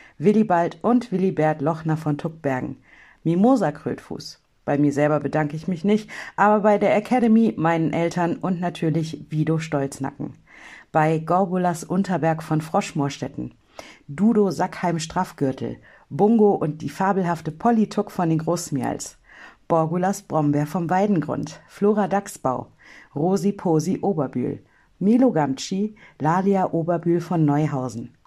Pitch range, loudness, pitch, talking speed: 150-195 Hz, -22 LUFS, 170 Hz, 120 wpm